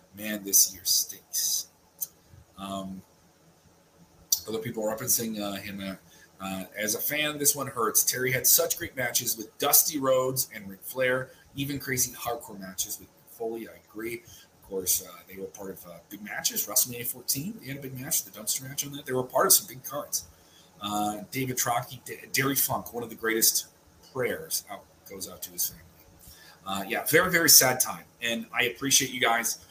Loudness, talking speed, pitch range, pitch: -26 LUFS, 190 wpm, 95-130 Hz, 115 Hz